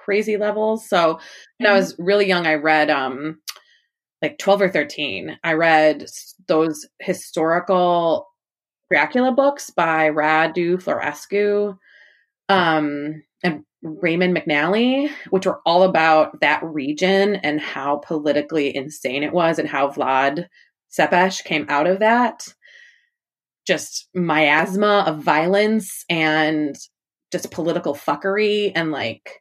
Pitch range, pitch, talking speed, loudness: 155-200 Hz, 170 Hz, 120 wpm, -19 LUFS